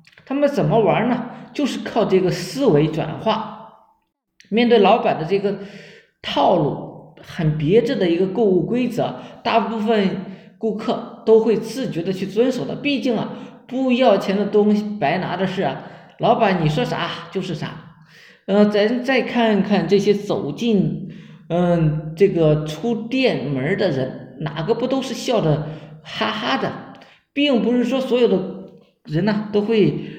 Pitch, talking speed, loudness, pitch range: 205 Hz, 220 characters per minute, -19 LUFS, 175-230 Hz